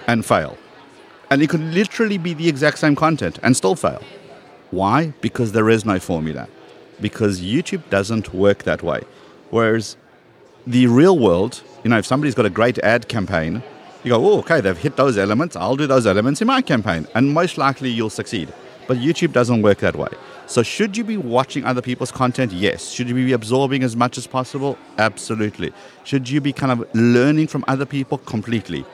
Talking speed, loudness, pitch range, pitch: 195 wpm, -18 LUFS, 110-140 Hz, 125 Hz